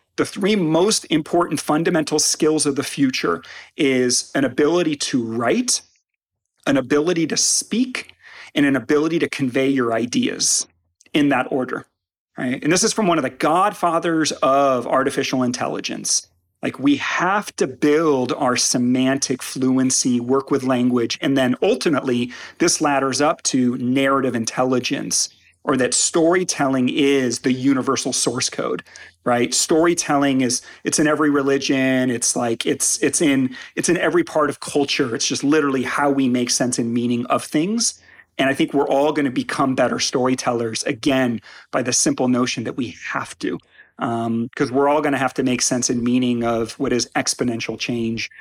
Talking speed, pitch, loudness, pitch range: 165 wpm, 135 Hz, -19 LUFS, 125-150 Hz